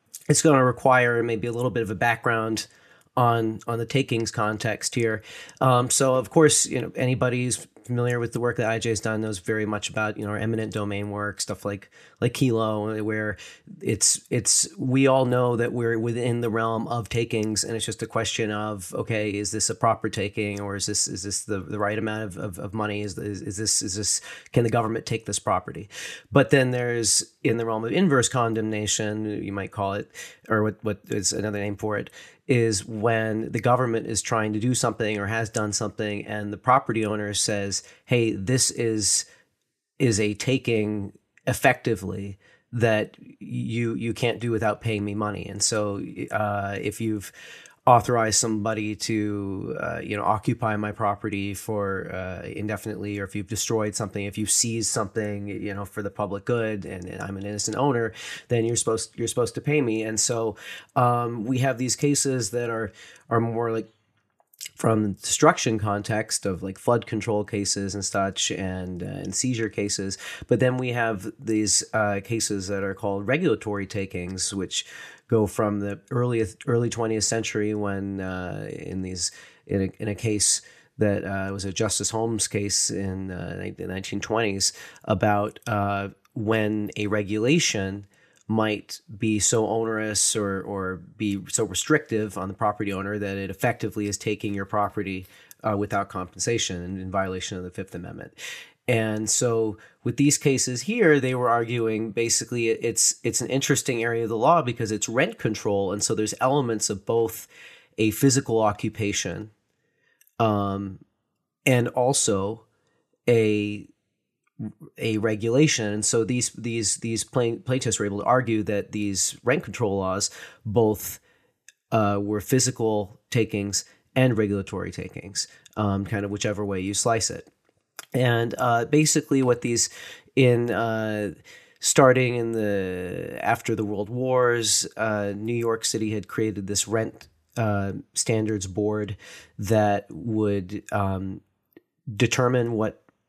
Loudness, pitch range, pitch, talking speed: -25 LUFS, 100-115 Hz, 110 Hz, 170 wpm